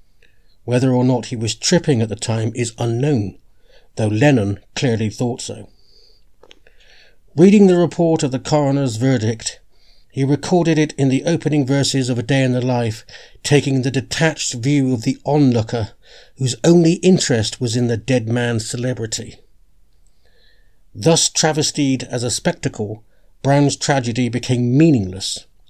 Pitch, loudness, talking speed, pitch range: 130 Hz, -17 LUFS, 140 wpm, 120-145 Hz